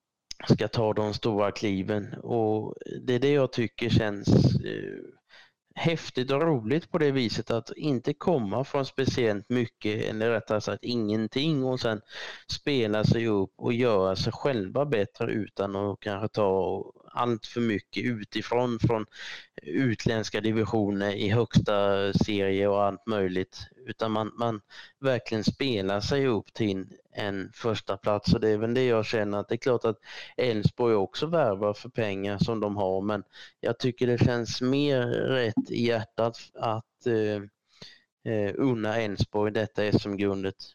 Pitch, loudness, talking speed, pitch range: 110 Hz, -28 LUFS, 150 wpm, 105-120 Hz